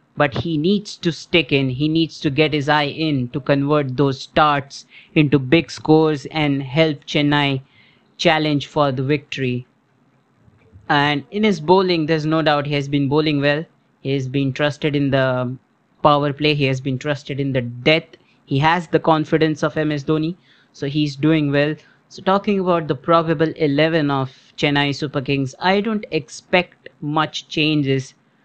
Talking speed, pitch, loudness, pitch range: 170 wpm, 150 Hz, -19 LUFS, 140-160 Hz